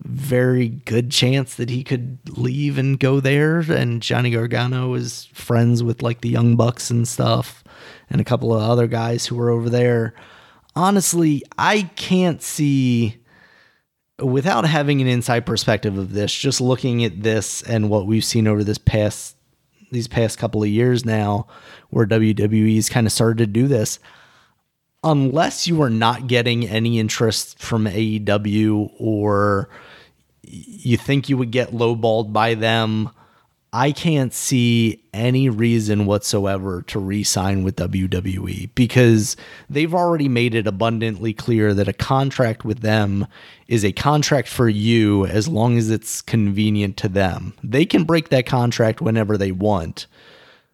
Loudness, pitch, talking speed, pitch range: -19 LUFS, 115 Hz, 155 wpm, 110-130 Hz